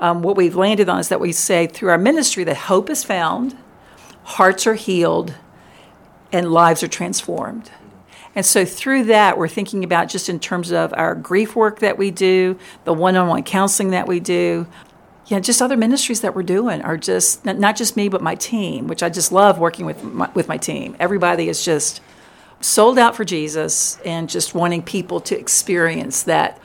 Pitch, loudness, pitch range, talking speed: 185 Hz, -17 LUFS, 170-210 Hz, 195 wpm